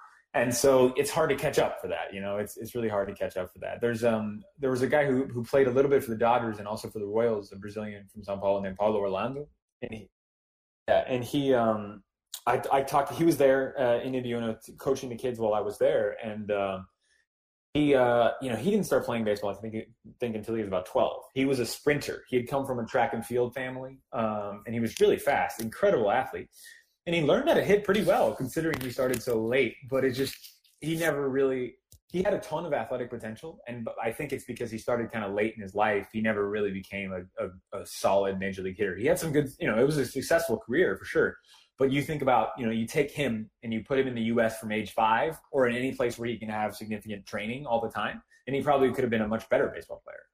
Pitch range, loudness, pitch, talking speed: 105-135 Hz, -28 LUFS, 120 Hz, 260 wpm